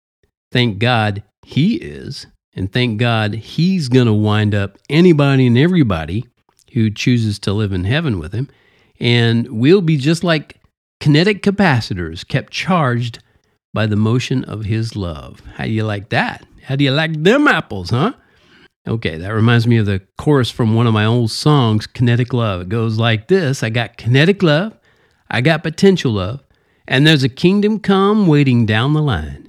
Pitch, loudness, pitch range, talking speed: 120 Hz, -15 LUFS, 110-145 Hz, 175 wpm